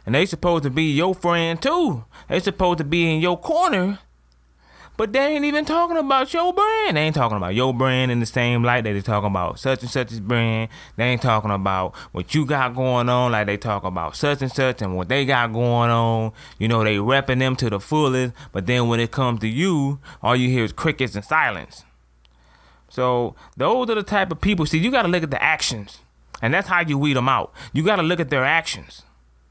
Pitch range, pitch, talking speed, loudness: 110-165 Hz, 130 Hz, 230 wpm, -21 LUFS